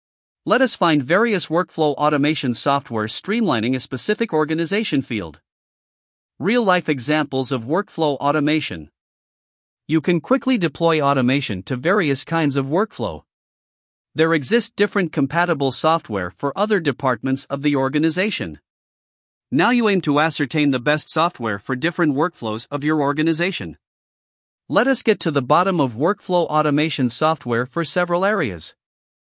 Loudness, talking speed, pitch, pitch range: -20 LUFS, 135 wpm, 150 Hz, 130-175 Hz